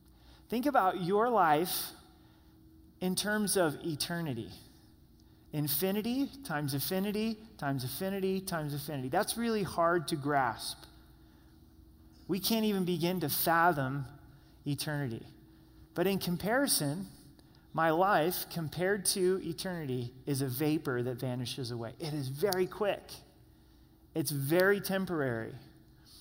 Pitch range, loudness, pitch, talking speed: 130-190 Hz, -32 LUFS, 160 Hz, 110 wpm